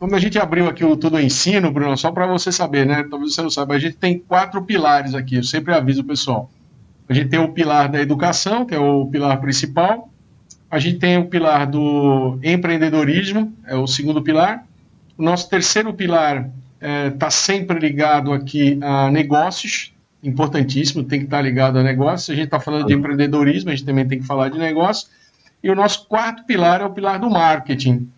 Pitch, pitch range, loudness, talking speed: 150 Hz, 140-175 Hz, -17 LUFS, 205 wpm